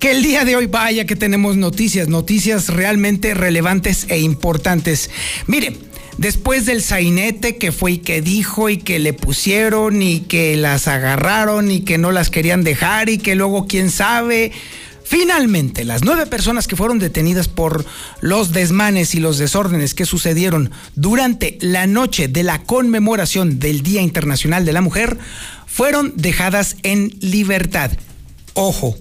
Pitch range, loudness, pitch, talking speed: 165-215 Hz, -15 LUFS, 190 Hz, 155 wpm